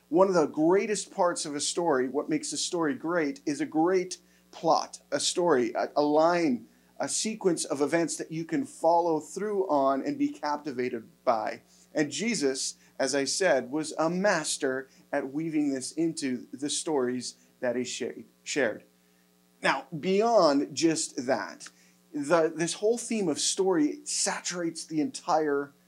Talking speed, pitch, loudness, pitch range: 155 wpm, 155 Hz, -28 LUFS, 135-185 Hz